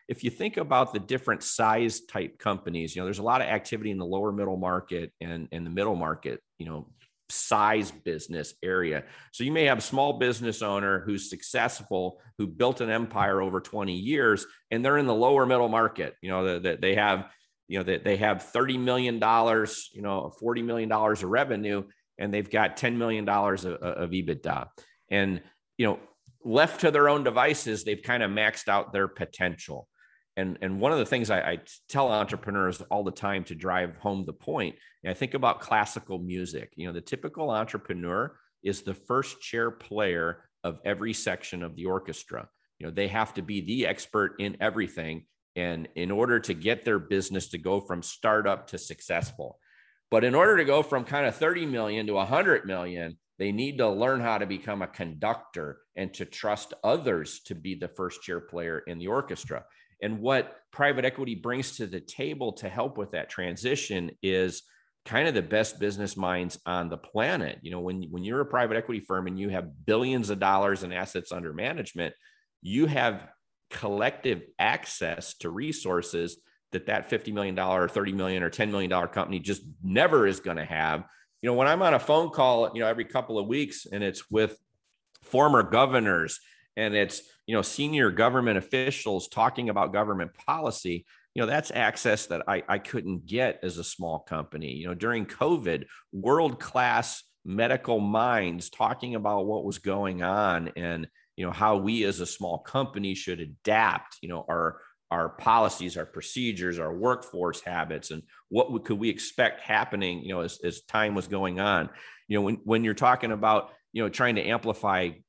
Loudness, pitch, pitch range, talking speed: -28 LUFS, 100 Hz, 90-115 Hz, 190 wpm